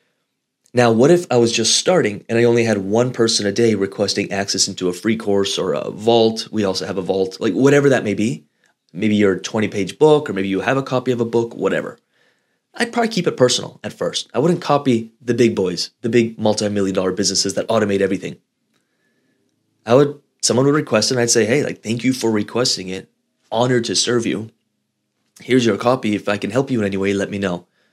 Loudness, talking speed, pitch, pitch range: -18 LUFS, 220 wpm, 115 Hz, 100-125 Hz